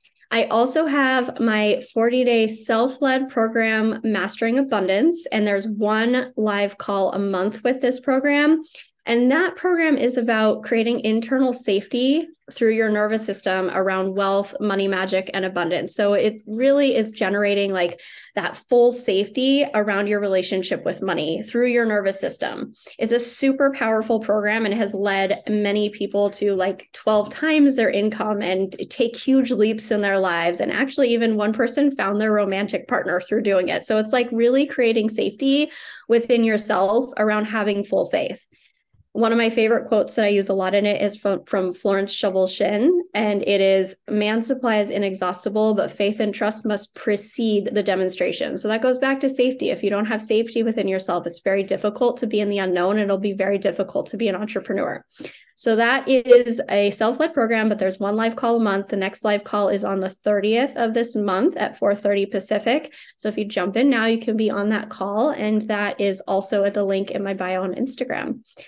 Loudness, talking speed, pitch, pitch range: -21 LUFS, 190 wpm, 215 Hz, 200-240 Hz